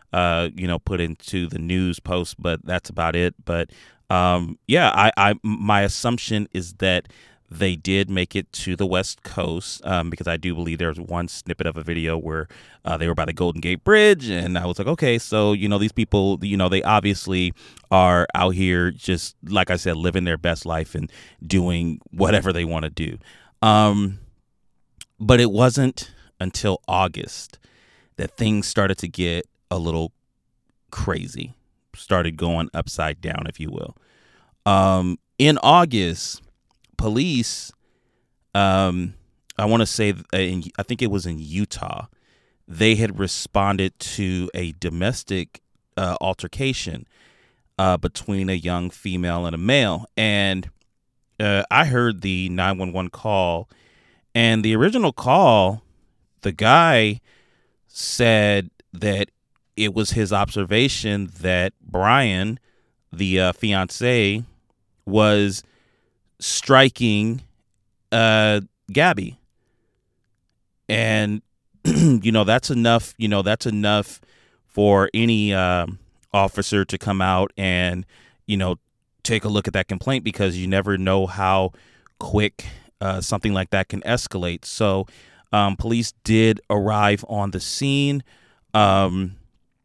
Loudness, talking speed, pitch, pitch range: -21 LUFS, 140 wpm, 100 Hz, 90-110 Hz